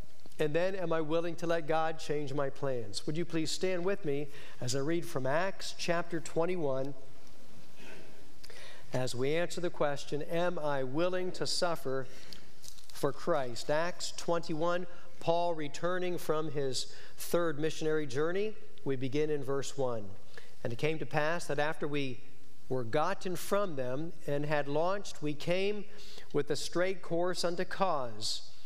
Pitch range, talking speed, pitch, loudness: 140-175 Hz, 155 wpm, 155 Hz, -35 LUFS